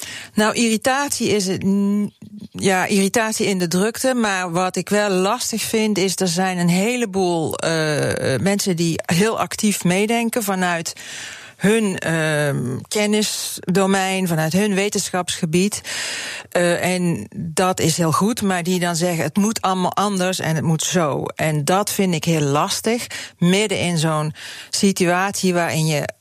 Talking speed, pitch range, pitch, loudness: 145 wpm, 175-205 Hz, 185 Hz, -19 LUFS